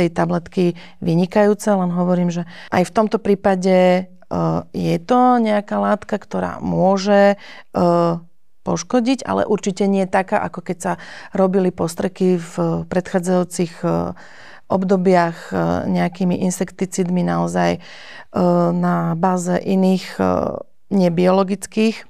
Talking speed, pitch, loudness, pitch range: 100 wpm, 185 Hz, -18 LUFS, 175-200 Hz